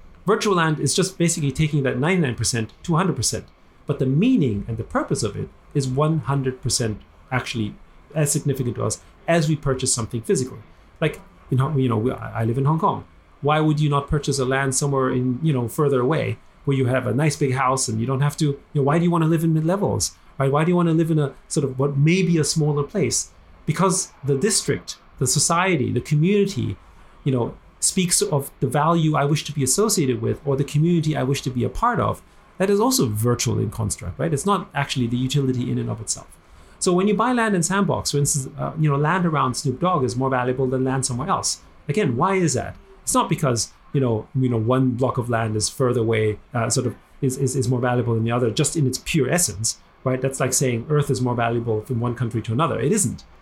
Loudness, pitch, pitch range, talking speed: -21 LUFS, 135 Hz, 120-155 Hz, 230 wpm